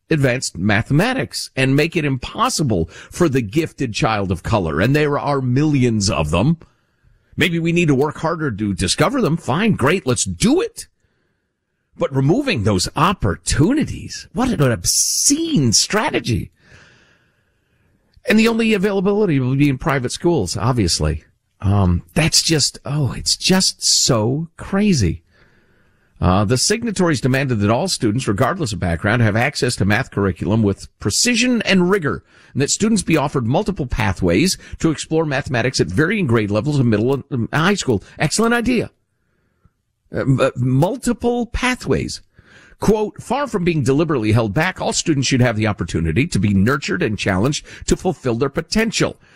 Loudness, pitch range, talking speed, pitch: -17 LUFS, 110-165 Hz, 150 wpm, 135 Hz